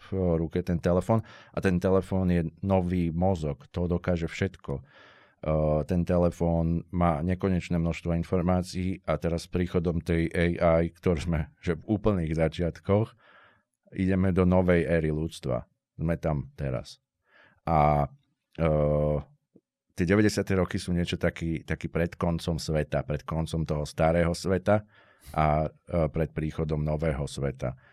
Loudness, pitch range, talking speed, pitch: -28 LUFS, 80-90 Hz, 135 wpm, 85 Hz